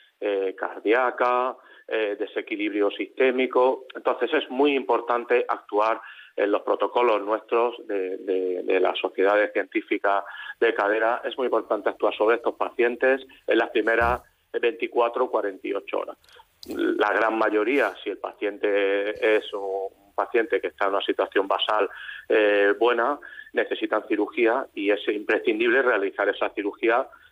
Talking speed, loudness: 130 wpm, -24 LUFS